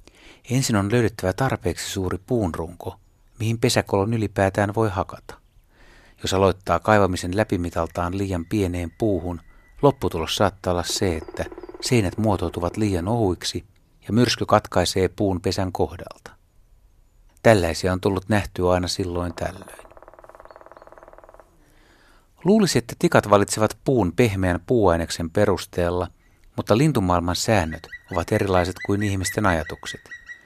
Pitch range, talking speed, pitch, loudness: 90-110 Hz, 110 wpm, 100 Hz, -22 LUFS